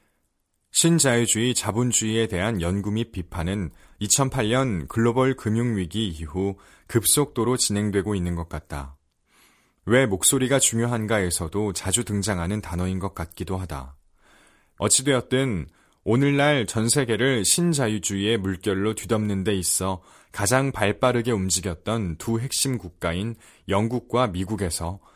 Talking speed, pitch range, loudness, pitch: 280 characters per minute, 95-120 Hz, -23 LUFS, 105 Hz